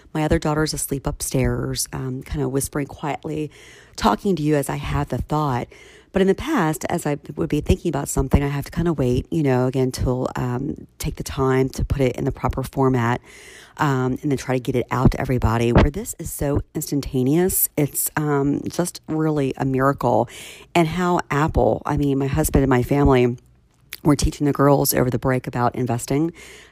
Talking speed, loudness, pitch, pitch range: 200 wpm, -21 LUFS, 140 Hz, 125-150 Hz